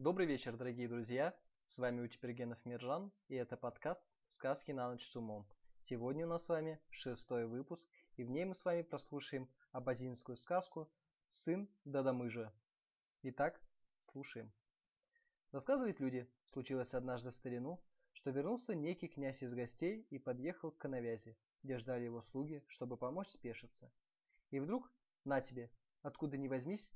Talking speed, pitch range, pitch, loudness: 145 wpm, 125-165 Hz, 130 Hz, -45 LUFS